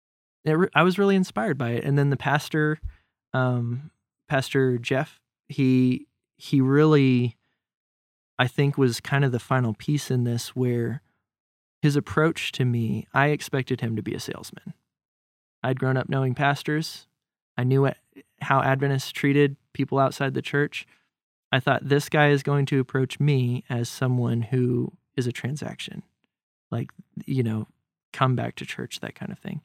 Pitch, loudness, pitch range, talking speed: 135 Hz, -24 LUFS, 125-145 Hz, 160 wpm